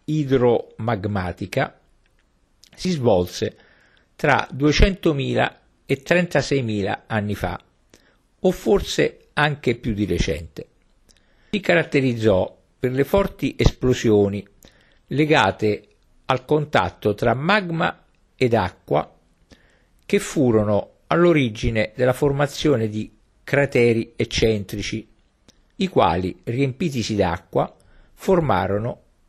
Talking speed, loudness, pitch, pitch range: 85 wpm, -21 LUFS, 120 Hz, 105-150 Hz